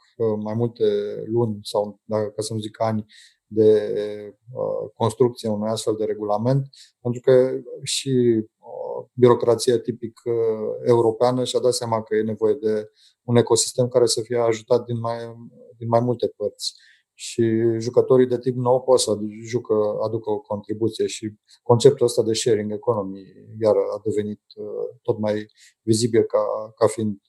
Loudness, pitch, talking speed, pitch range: -22 LUFS, 115 Hz, 145 wpm, 110-125 Hz